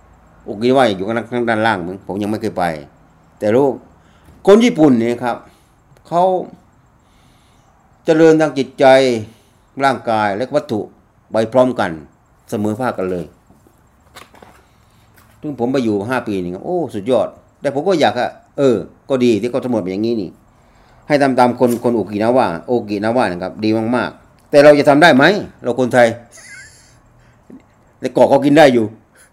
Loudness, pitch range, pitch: -15 LUFS, 105-130 Hz, 115 Hz